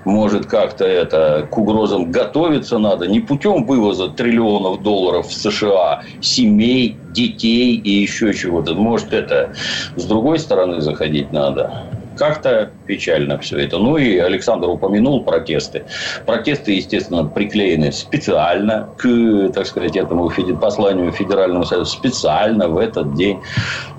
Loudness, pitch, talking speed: -16 LUFS, 110 Hz, 130 wpm